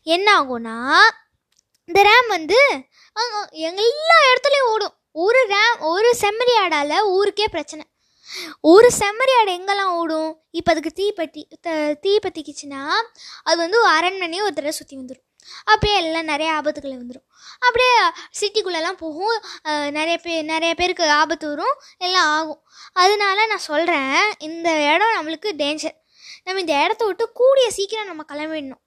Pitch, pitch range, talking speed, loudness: 345 Hz, 310-415 Hz, 135 wpm, -18 LUFS